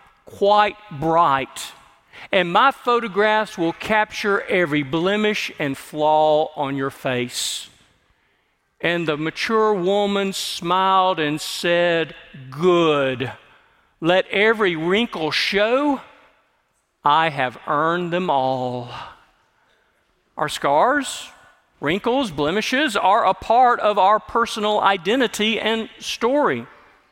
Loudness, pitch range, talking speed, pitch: -20 LUFS, 155-215 Hz, 95 wpm, 185 Hz